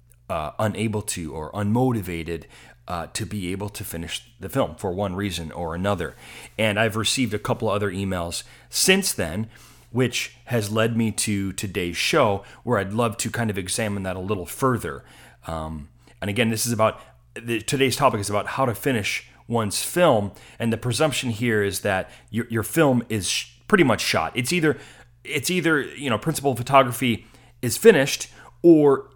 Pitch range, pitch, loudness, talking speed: 100-125 Hz, 110 Hz, -23 LUFS, 180 wpm